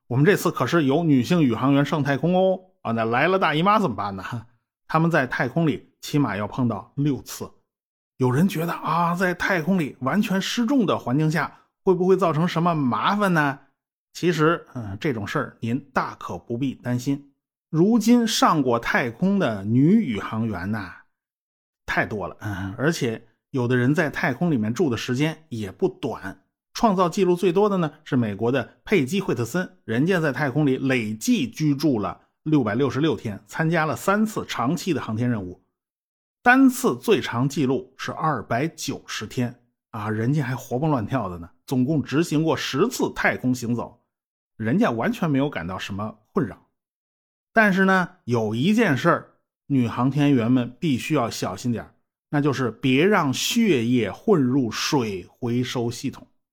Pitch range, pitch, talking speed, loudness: 120-170 Hz, 140 Hz, 255 characters per minute, -23 LUFS